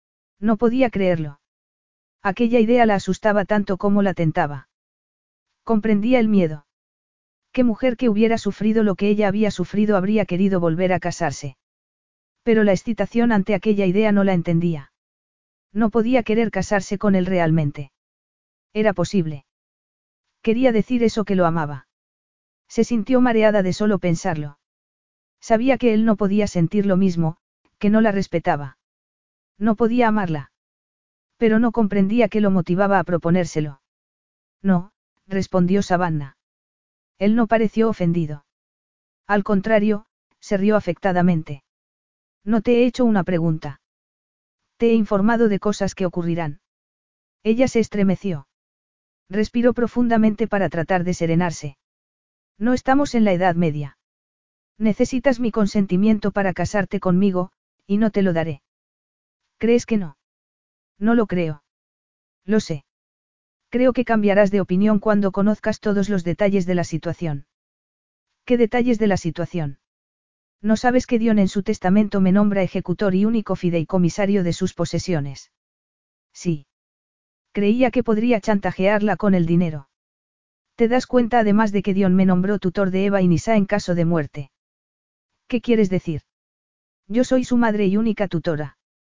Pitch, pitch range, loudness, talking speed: 200 Hz, 175-220 Hz, -20 LUFS, 140 wpm